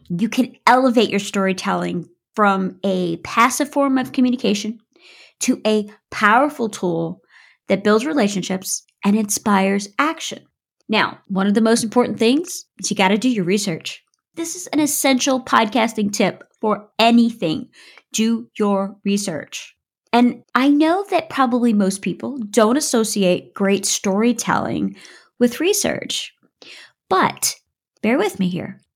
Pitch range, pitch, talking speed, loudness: 195-255 Hz, 220 Hz, 135 wpm, -19 LUFS